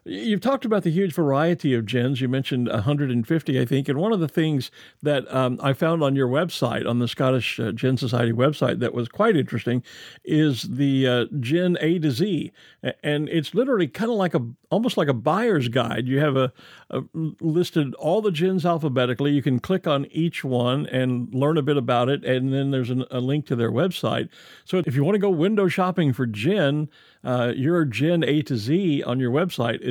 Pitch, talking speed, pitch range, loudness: 140 Hz, 210 wpm, 130-165 Hz, -23 LUFS